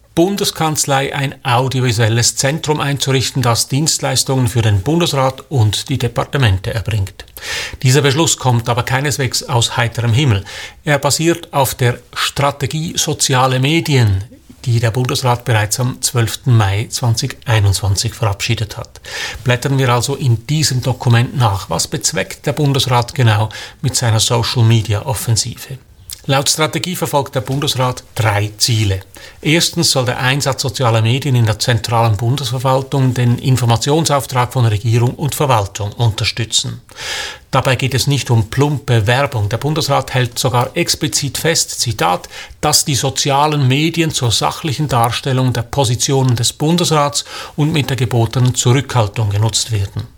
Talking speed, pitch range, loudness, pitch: 130 wpm, 115-140 Hz, -15 LUFS, 125 Hz